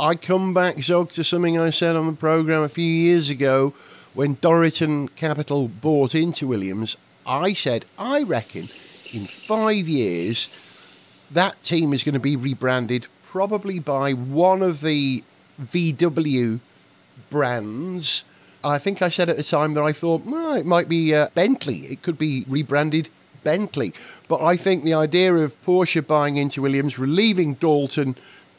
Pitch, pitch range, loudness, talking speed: 155 Hz, 140-175 Hz, -21 LUFS, 155 wpm